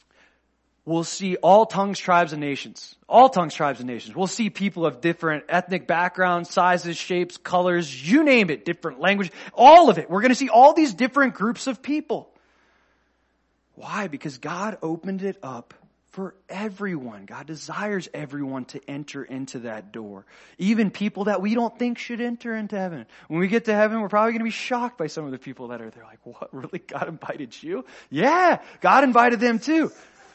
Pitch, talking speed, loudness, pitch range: 185 Hz, 190 wpm, -21 LUFS, 160-225 Hz